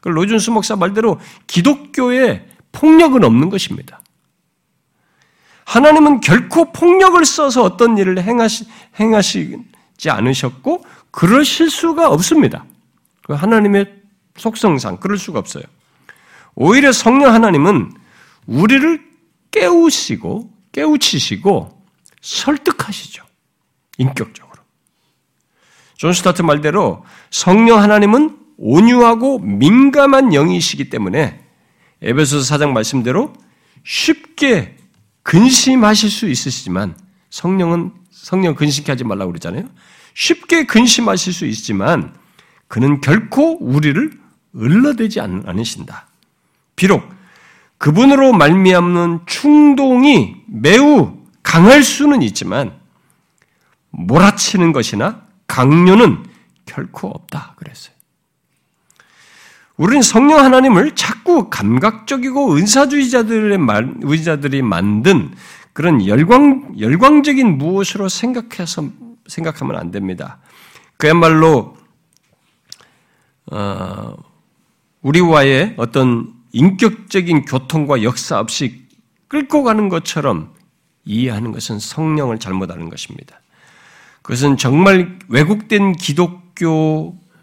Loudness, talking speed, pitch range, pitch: -12 LUFS, 235 characters per minute, 155-255 Hz, 200 Hz